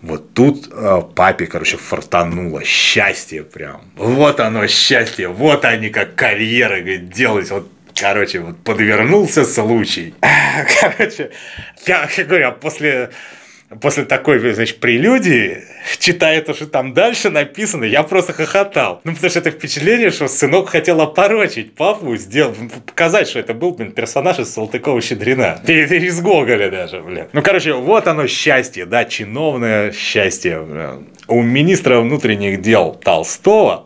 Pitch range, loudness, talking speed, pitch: 115-165 Hz, -14 LUFS, 140 wpm, 145 Hz